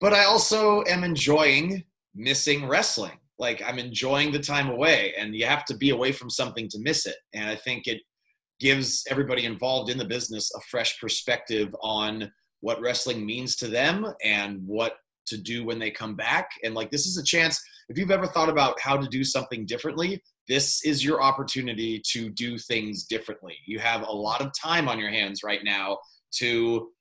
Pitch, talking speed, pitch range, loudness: 125 Hz, 195 wpm, 115-145 Hz, -25 LUFS